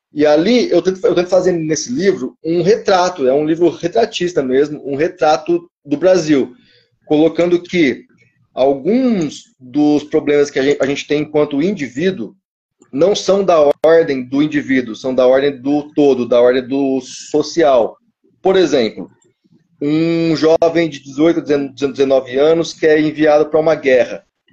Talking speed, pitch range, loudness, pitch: 145 wpm, 140-170 Hz, -14 LUFS, 155 Hz